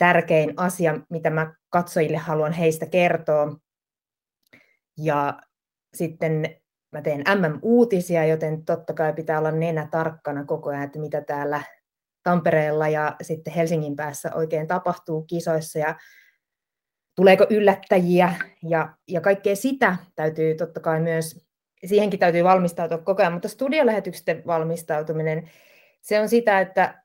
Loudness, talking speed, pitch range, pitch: -22 LUFS, 125 wpm, 155-180 Hz, 165 Hz